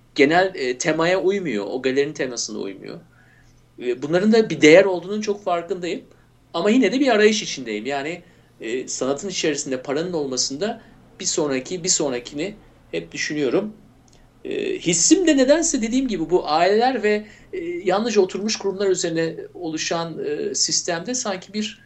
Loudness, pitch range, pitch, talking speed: -21 LUFS, 160-225 Hz, 185 Hz, 145 wpm